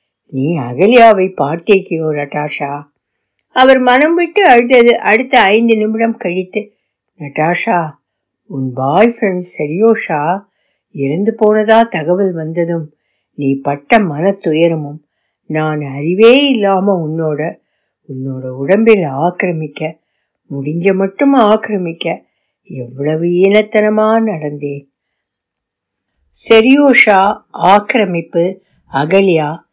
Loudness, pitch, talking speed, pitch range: -12 LUFS, 175 Hz, 80 wpm, 145-215 Hz